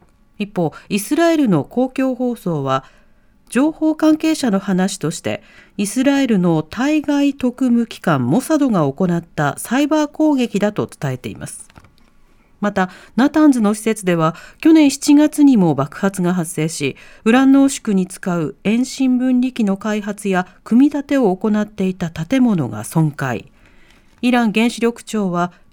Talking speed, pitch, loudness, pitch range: 275 characters per minute, 215 Hz, -17 LUFS, 175-265 Hz